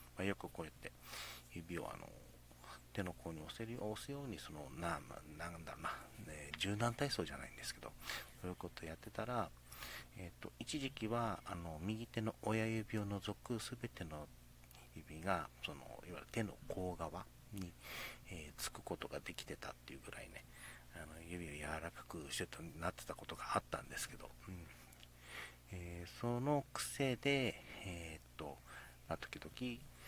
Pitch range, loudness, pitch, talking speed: 75-115 Hz, -46 LUFS, 90 Hz, 290 characters per minute